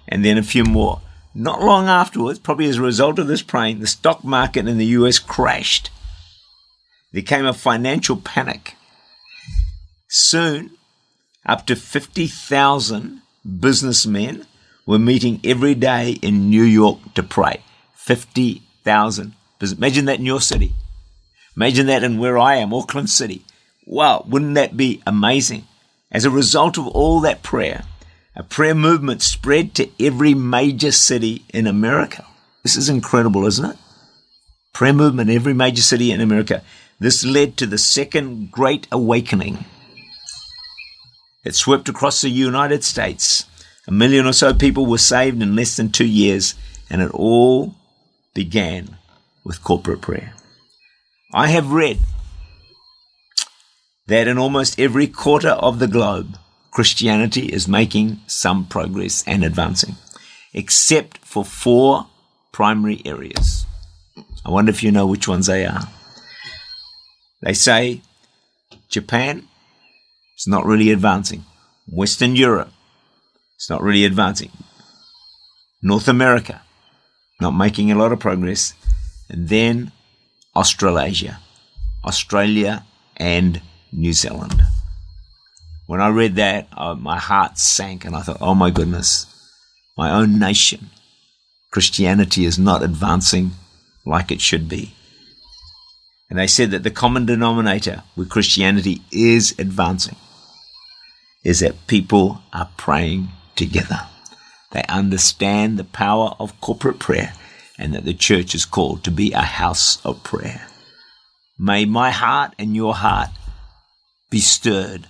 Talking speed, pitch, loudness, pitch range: 130 wpm, 110 Hz, -16 LUFS, 95-130 Hz